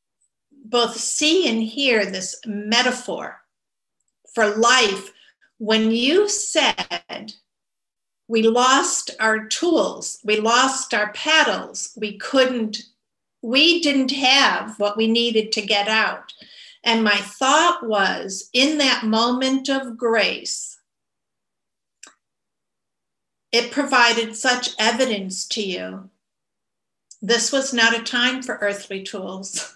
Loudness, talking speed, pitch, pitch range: -19 LUFS, 105 wpm, 230 Hz, 215-265 Hz